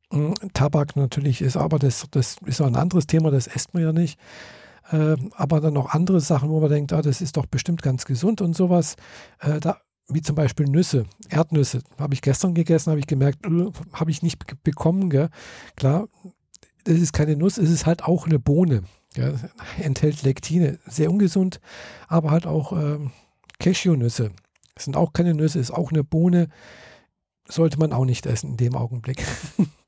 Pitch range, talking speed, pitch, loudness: 140-170 Hz, 170 wpm, 155 Hz, -22 LUFS